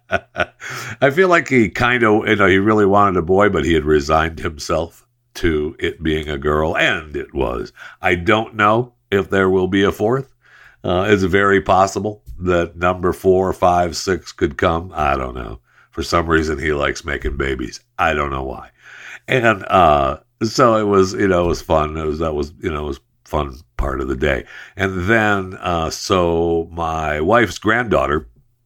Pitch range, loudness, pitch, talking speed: 80-105 Hz, -17 LUFS, 90 Hz, 190 wpm